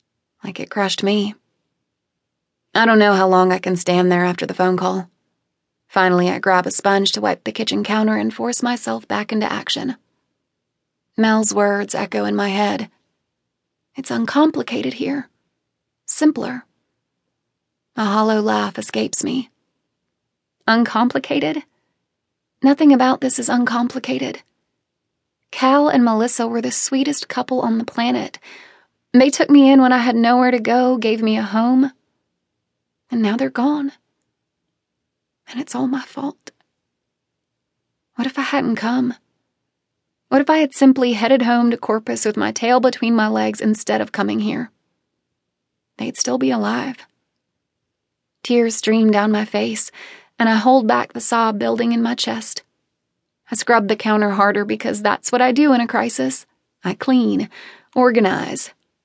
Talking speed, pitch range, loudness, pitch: 150 wpm, 210-255 Hz, -17 LUFS, 235 Hz